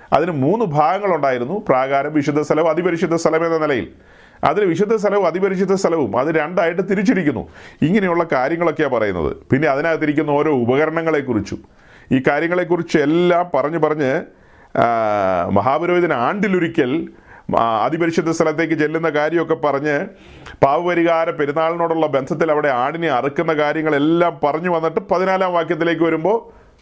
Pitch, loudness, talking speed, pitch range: 165 Hz, -18 LUFS, 110 wpm, 150-175 Hz